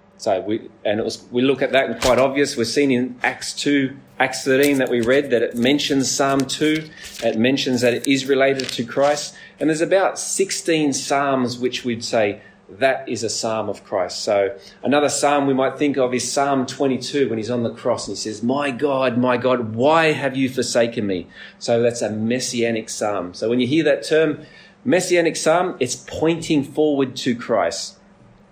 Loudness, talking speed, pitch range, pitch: -20 LUFS, 200 wpm, 125-145 Hz, 135 Hz